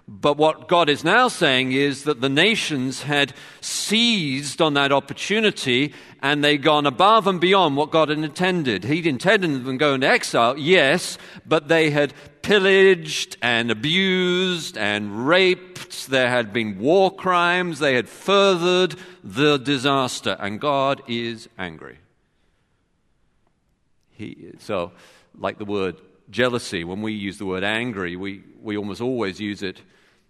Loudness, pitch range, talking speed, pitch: -20 LUFS, 120-180 Hz, 145 wpm, 145 Hz